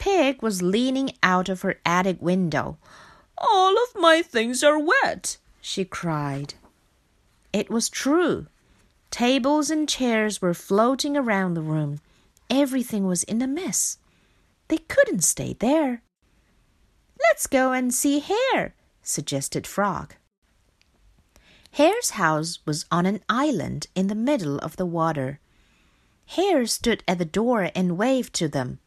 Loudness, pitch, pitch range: -23 LUFS, 215 Hz, 170-285 Hz